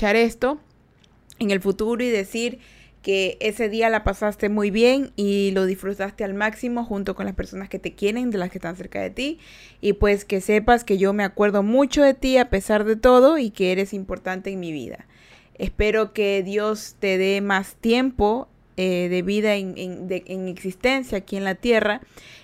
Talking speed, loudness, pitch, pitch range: 195 wpm, -22 LUFS, 205 Hz, 195-230 Hz